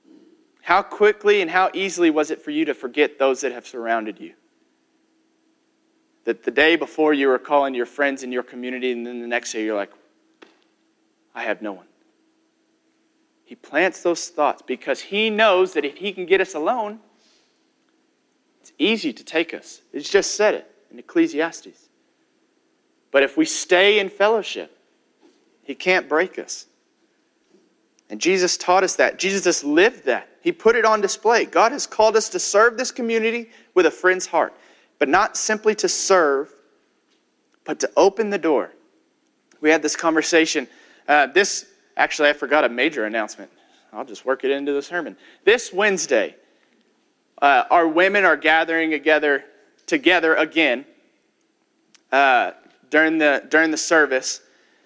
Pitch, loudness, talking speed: 210 Hz, -19 LUFS, 160 wpm